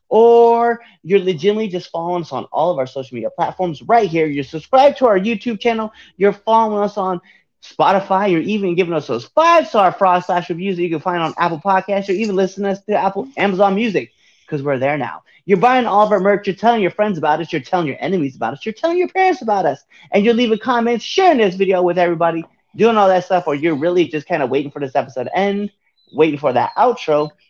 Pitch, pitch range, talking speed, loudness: 190 Hz, 165-220 Hz, 230 wpm, -16 LUFS